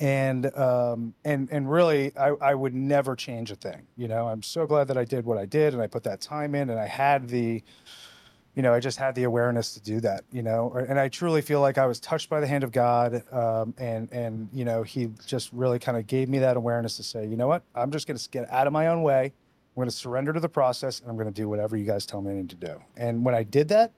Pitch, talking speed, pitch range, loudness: 125 Hz, 275 wpm, 115-140 Hz, -26 LUFS